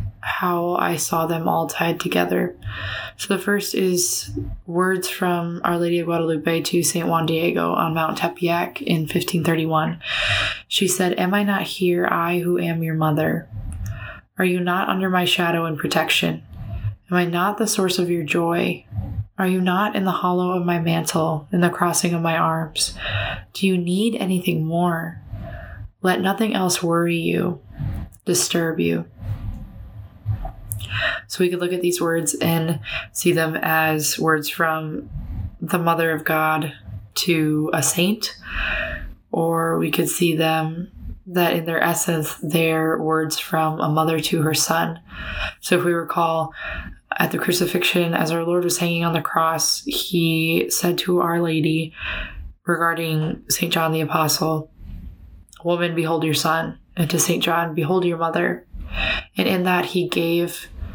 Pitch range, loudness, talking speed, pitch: 155-175 Hz, -21 LUFS, 155 wpm, 165 Hz